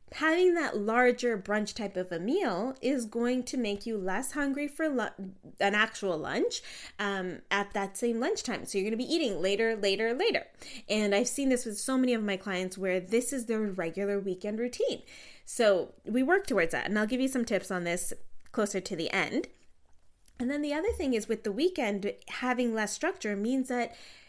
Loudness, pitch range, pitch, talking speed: -30 LUFS, 200-260 Hz, 225 Hz, 205 wpm